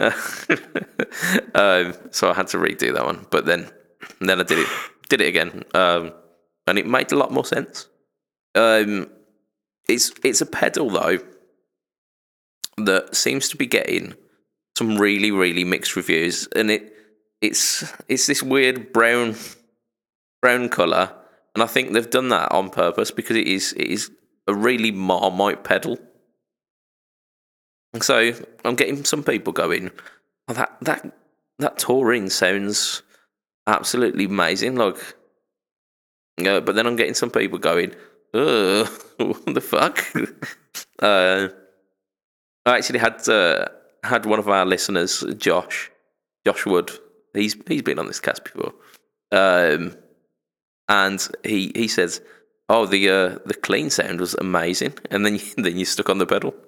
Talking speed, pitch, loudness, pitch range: 145 wpm, 105 Hz, -20 LUFS, 95-115 Hz